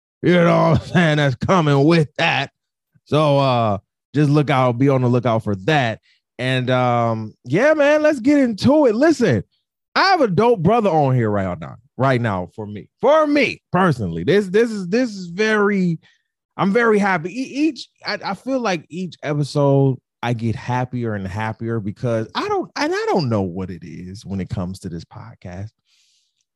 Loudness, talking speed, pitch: -18 LUFS, 185 wpm, 145 Hz